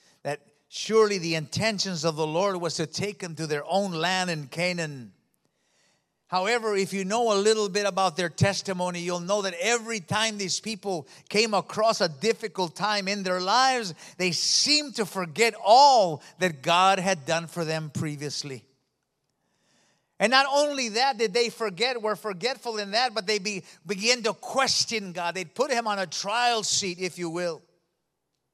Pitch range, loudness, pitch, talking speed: 170-220 Hz, -25 LUFS, 195 Hz, 170 wpm